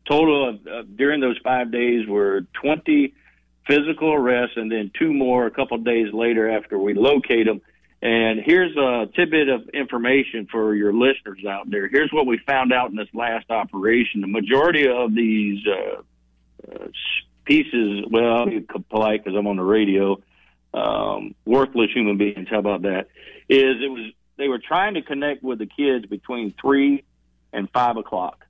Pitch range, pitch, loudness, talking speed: 105-135 Hz, 115 Hz, -20 LUFS, 175 wpm